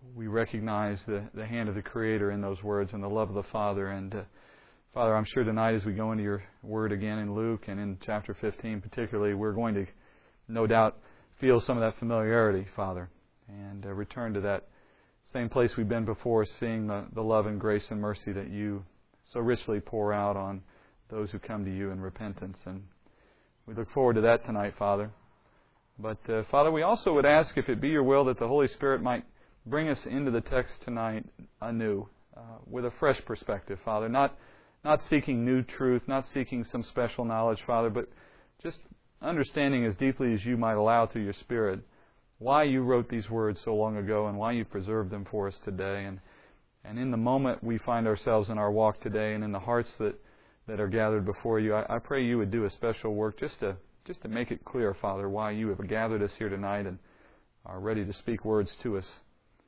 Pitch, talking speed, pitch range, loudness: 110 Hz, 210 wpm, 100-115 Hz, -30 LUFS